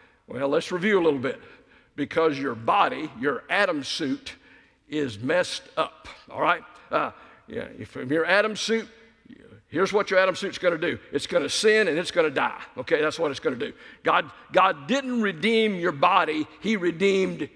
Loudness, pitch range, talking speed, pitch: -24 LUFS, 160-215 Hz, 190 wpm, 190 Hz